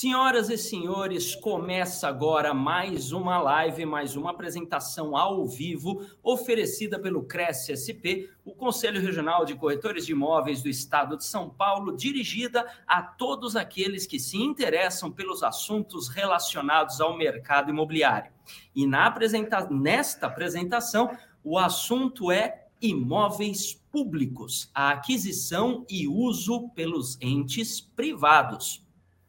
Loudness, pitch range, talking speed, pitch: -27 LUFS, 155-225 Hz, 120 wpm, 185 Hz